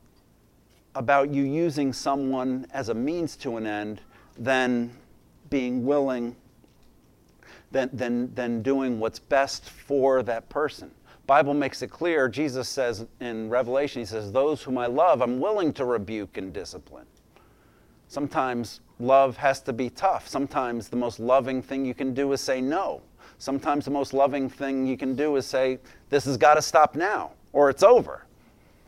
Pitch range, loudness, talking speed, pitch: 120-140 Hz, -25 LUFS, 160 wpm, 130 Hz